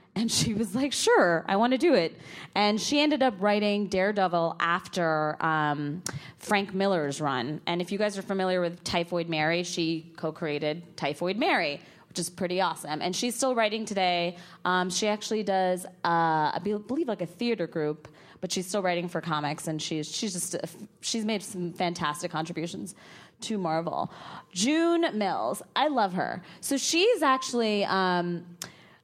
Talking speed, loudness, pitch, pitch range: 170 wpm, -28 LUFS, 180 Hz, 165-210 Hz